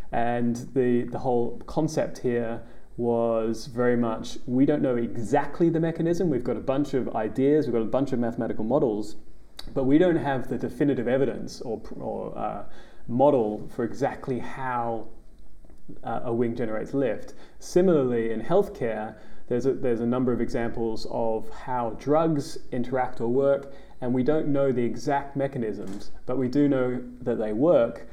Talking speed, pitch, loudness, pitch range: 165 wpm, 120 Hz, -26 LUFS, 115-140 Hz